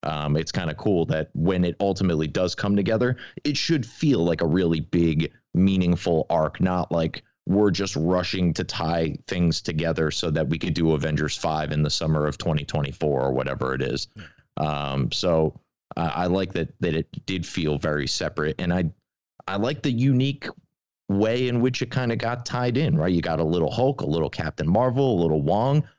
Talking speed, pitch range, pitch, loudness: 205 wpm, 80-115 Hz, 90 Hz, -24 LUFS